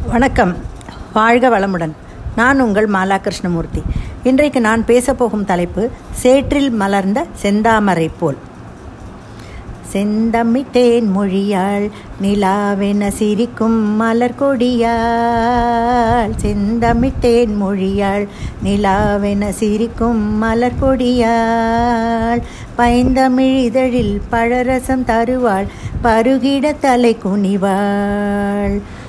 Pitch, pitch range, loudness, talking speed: 225 Hz, 200-240 Hz, -15 LUFS, 70 wpm